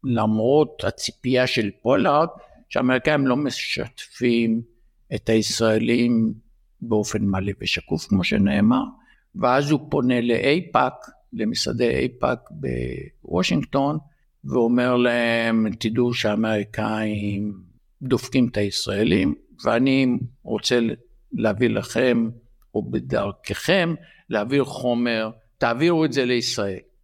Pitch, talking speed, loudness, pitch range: 120 Hz, 90 wpm, -22 LUFS, 110-130 Hz